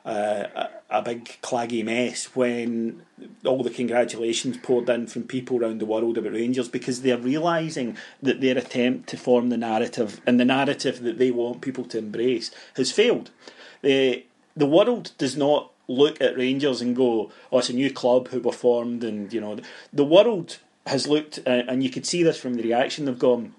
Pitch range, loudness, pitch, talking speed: 120-135 Hz, -24 LUFS, 125 Hz, 190 wpm